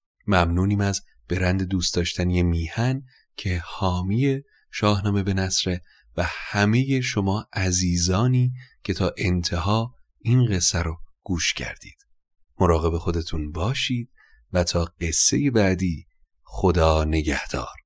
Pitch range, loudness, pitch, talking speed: 85-105 Hz, -23 LUFS, 95 Hz, 110 wpm